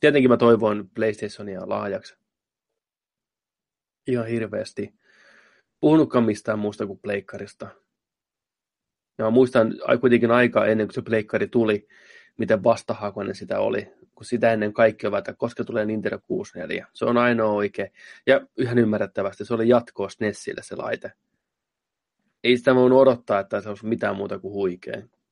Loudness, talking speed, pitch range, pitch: -22 LUFS, 135 wpm, 105-125 Hz, 115 Hz